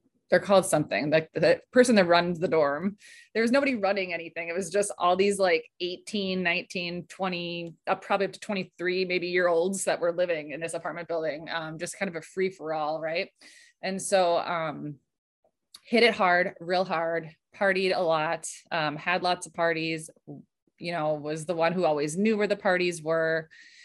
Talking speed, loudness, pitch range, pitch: 195 wpm, -27 LUFS, 165-195 Hz, 180 Hz